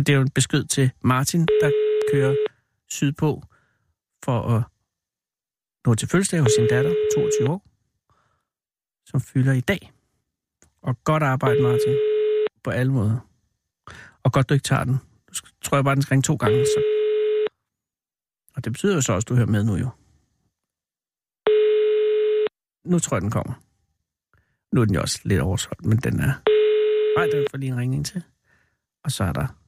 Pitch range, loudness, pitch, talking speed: 125-175 Hz, -22 LUFS, 140 Hz, 170 wpm